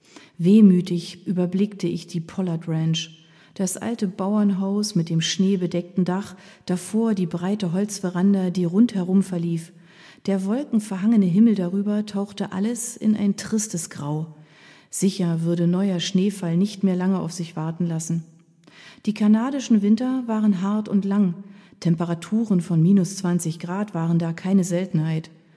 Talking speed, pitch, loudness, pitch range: 135 wpm, 185 Hz, -22 LUFS, 170-200 Hz